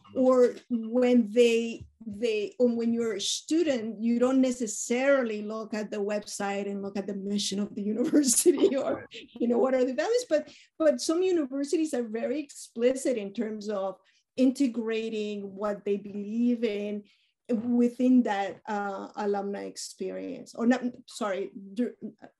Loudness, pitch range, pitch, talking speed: -28 LUFS, 205-255 Hz, 230 Hz, 145 wpm